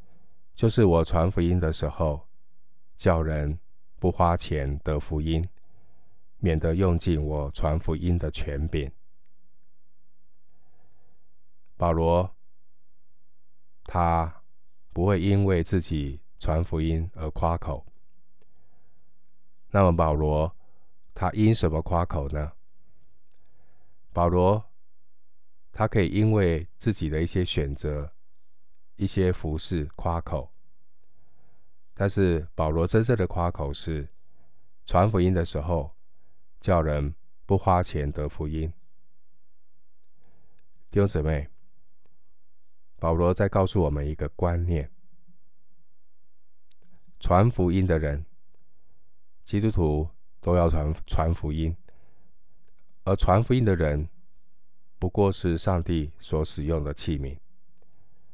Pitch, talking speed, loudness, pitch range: 85 Hz, 150 characters per minute, -26 LUFS, 80-95 Hz